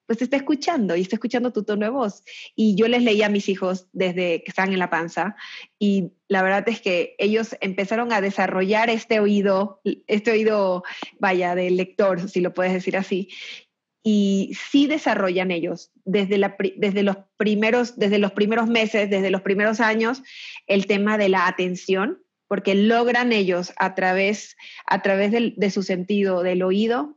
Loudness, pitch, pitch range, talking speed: -21 LUFS, 200 Hz, 190-220 Hz, 175 wpm